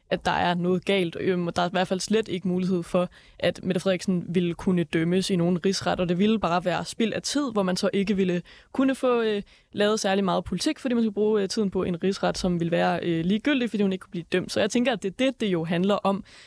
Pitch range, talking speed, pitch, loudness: 180-210 Hz, 260 wpm, 190 Hz, -25 LUFS